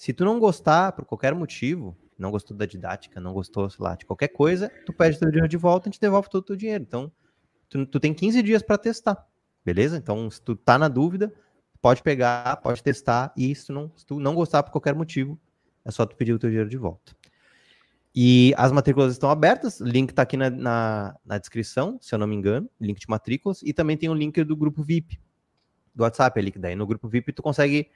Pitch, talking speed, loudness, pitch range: 140 Hz, 240 wpm, -23 LUFS, 115-165 Hz